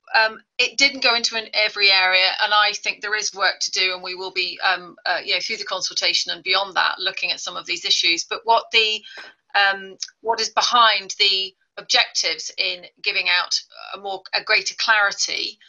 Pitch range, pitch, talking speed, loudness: 190-230 Hz, 215 Hz, 205 wpm, -19 LUFS